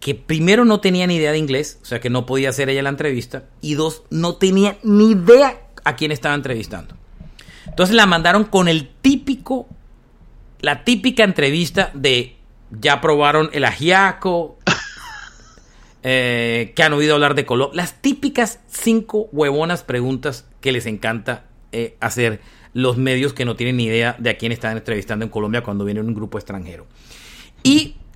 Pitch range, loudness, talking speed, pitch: 120-180 Hz, -17 LUFS, 165 wpm, 145 Hz